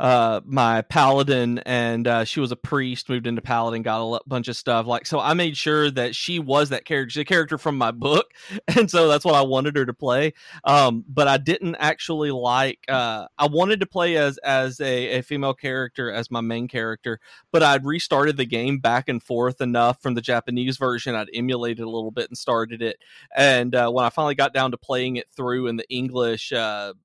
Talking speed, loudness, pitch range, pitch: 220 wpm, -22 LUFS, 120-145 Hz, 125 Hz